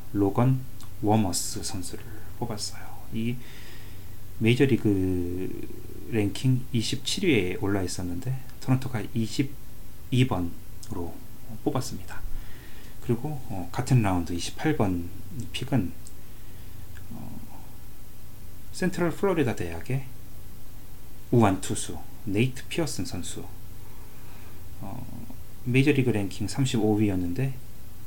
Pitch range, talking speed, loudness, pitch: 100-125 Hz, 185 characters per minute, -28 LUFS, 110 Hz